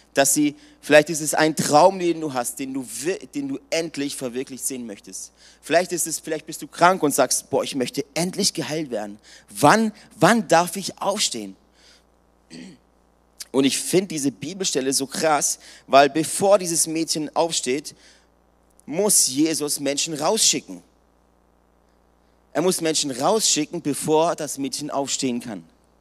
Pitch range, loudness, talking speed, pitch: 135-175 Hz, -21 LUFS, 145 wpm, 155 Hz